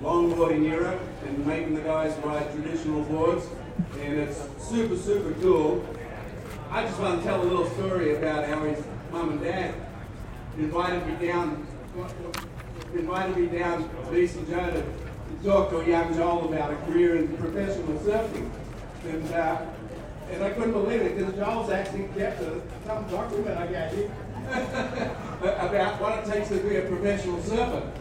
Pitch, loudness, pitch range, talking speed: 170 Hz, -28 LUFS, 155-195 Hz, 160 wpm